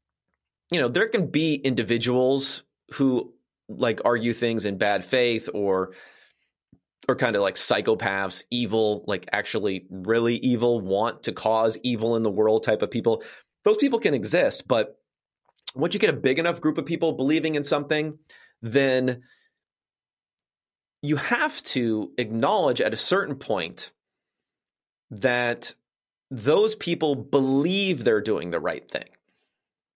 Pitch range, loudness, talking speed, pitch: 115-155 Hz, -24 LUFS, 140 wpm, 125 Hz